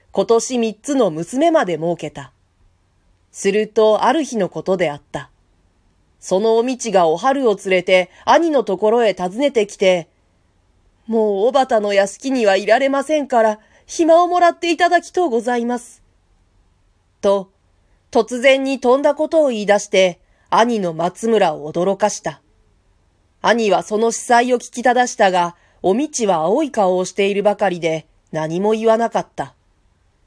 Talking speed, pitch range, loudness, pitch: 285 characters per minute, 155-235 Hz, -17 LUFS, 200 Hz